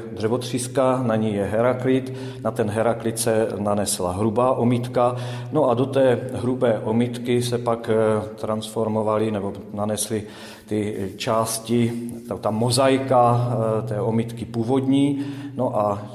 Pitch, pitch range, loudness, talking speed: 115 Hz, 110-125 Hz, -22 LUFS, 125 wpm